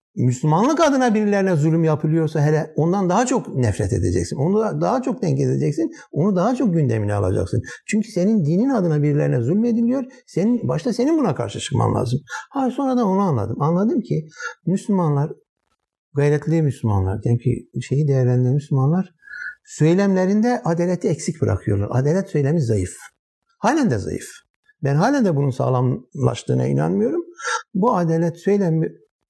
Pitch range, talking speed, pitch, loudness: 130-205 Hz, 140 wpm, 165 Hz, -20 LUFS